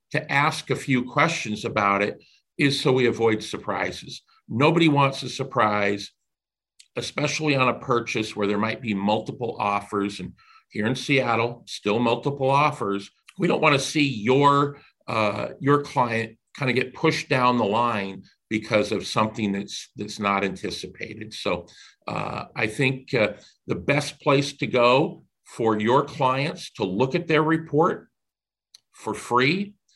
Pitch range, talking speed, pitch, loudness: 110-145 Hz, 150 wpm, 130 Hz, -23 LUFS